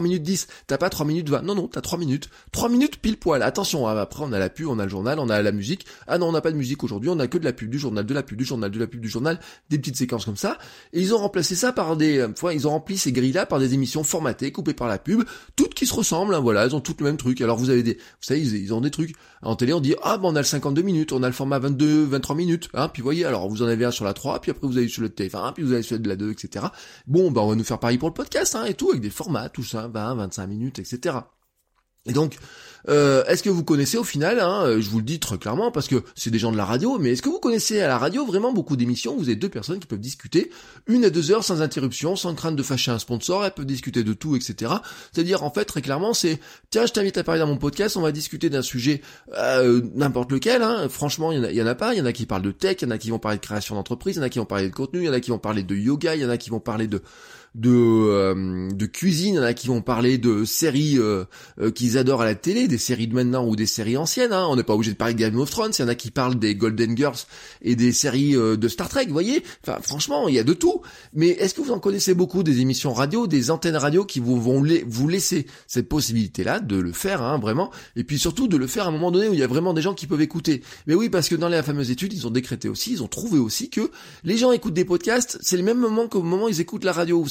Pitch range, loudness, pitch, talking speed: 120-170 Hz, -23 LUFS, 140 Hz, 310 wpm